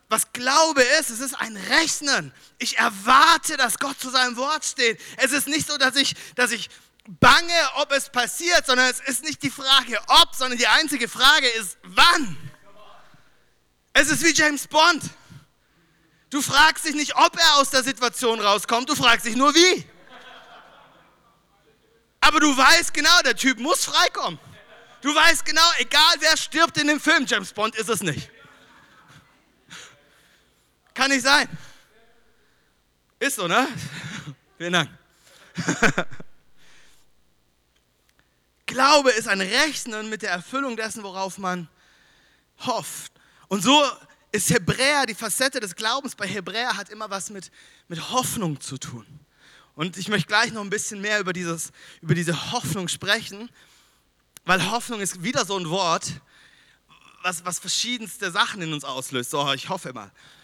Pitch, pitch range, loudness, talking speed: 235 Hz, 185-285 Hz, -20 LUFS, 150 wpm